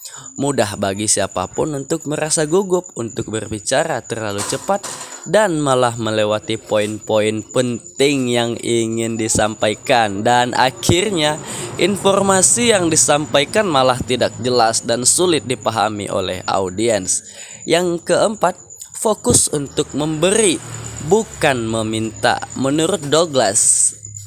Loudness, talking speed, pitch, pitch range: -16 LUFS, 100 wpm, 125 Hz, 110-160 Hz